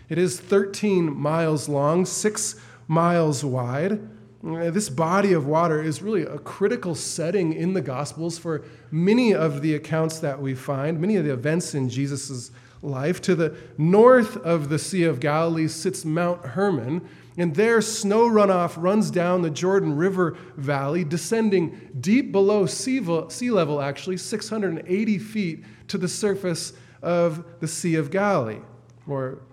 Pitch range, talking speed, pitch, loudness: 150-190 Hz, 150 wpm, 170 Hz, -23 LUFS